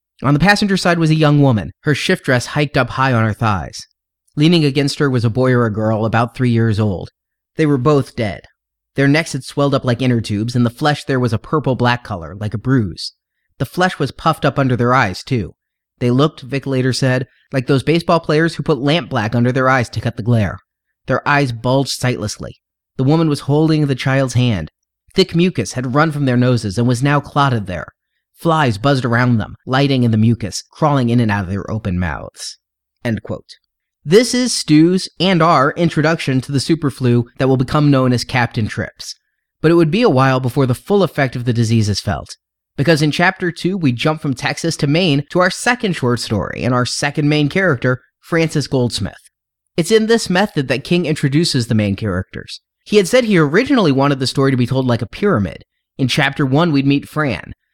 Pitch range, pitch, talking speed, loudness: 120-155 Hz, 135 Hz, 215 wpm, -16 LUFS